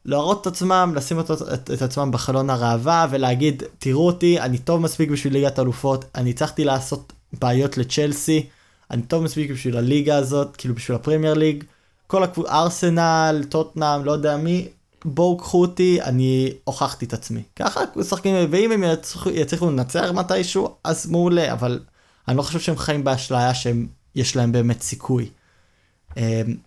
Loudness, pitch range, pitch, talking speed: -21 LUFS, 125-165 Hz, 145 Hz, 160 wpm